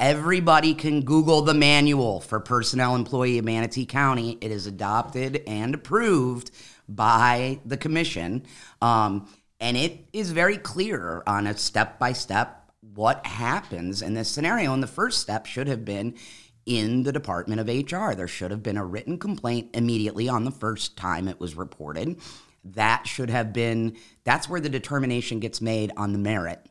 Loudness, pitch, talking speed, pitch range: -25 LUFS, 120 Hz, 170 wpm, 110-140 Hz